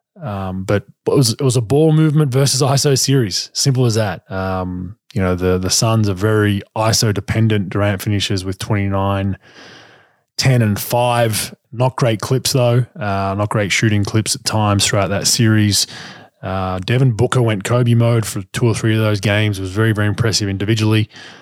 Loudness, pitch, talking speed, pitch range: -16 LUFS, 110 Hz, 180 wpm, 100-125 Hz